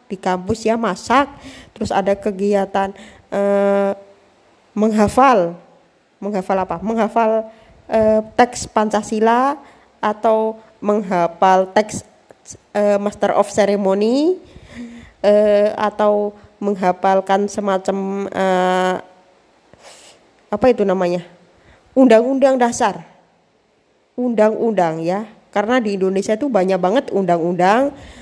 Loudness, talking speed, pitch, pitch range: -17 LUFS, 85 wpm, 205 Hz, 195-225 Hz